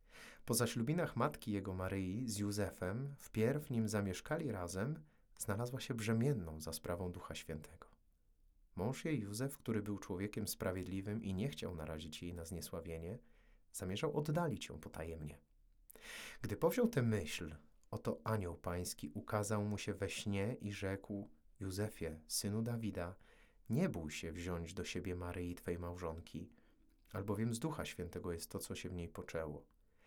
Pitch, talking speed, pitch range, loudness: 95 Hz, 145 wpm, 85-110 Hz, -42 LUFS